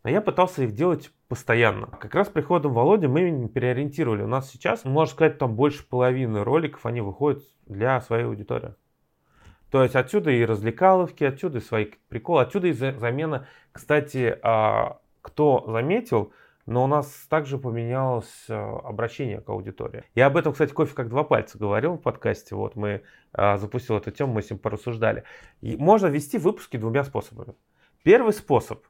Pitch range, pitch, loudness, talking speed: 115-150 Hz, 130 Hz, -24 LUFS, 160 wpm